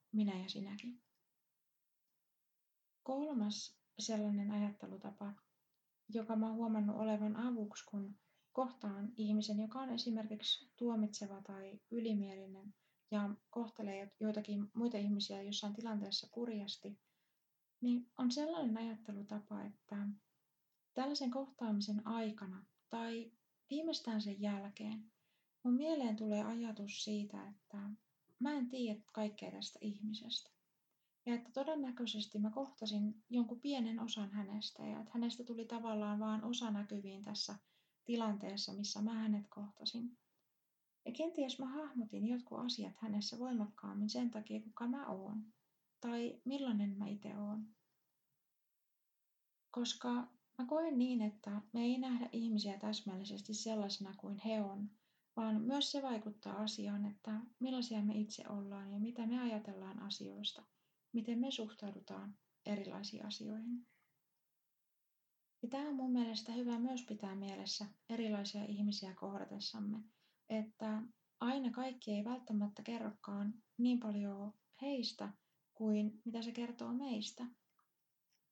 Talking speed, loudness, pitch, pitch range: 115 wpm, -42 LUFS, 215 Hz, 205-235 Hz